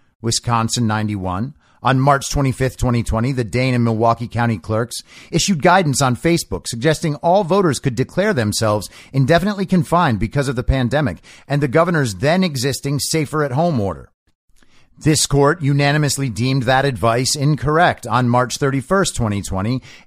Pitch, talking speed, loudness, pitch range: 130 Hz, 155 wpm, -17 LUFS, 115-150 Hz